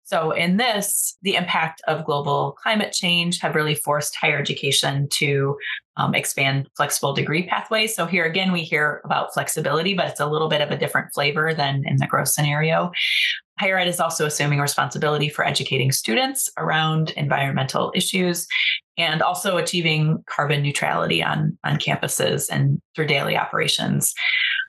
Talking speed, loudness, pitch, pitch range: 160 wpm, -21 LUFS, 155 Hz, 145-175 Hz